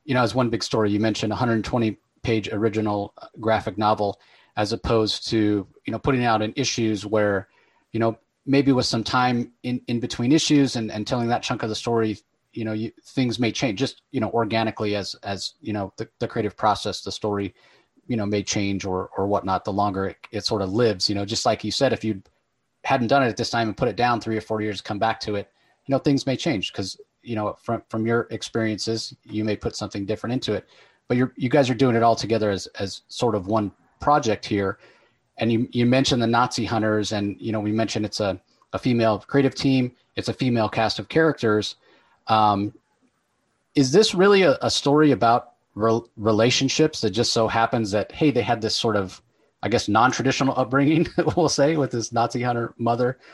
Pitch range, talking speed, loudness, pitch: 105-125 Hz, 215 wpm, -23 LUFS, 115 Hz